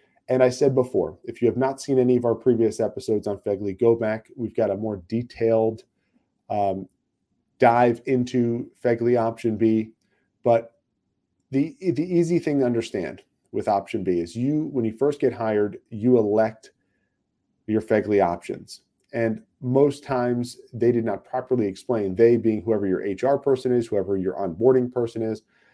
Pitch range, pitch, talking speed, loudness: 110-125 Hz, 115 Hz, 165 wpm, -23 LUFS